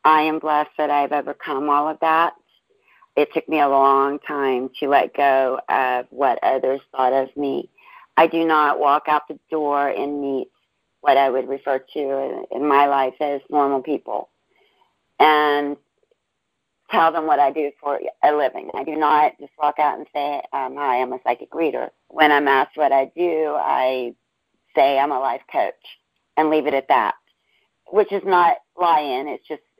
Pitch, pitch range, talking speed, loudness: 145 Hz, 135-155 Hz, 180 wpm, -20 LUFS